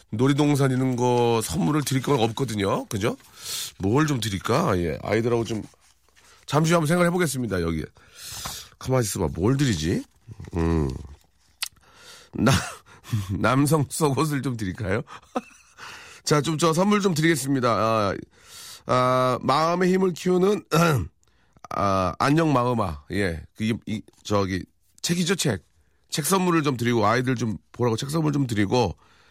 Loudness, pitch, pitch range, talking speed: -24 LUFS, 125 Hz, 100-150 Hz, 255 characters per minute